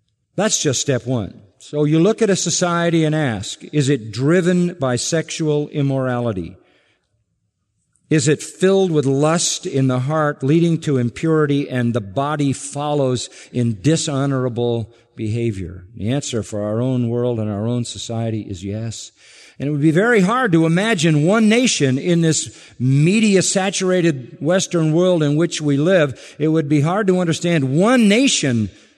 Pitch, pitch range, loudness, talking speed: 145 Hz, 120-170 Hz, -18 LUFS, 155 wpm